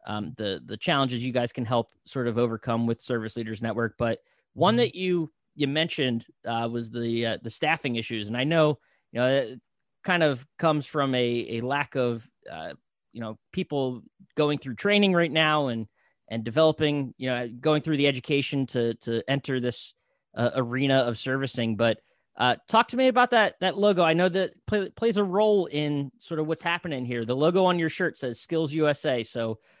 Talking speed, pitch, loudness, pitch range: 200 wpm, 135 Hz, -26 LUFS, 120-160 Hz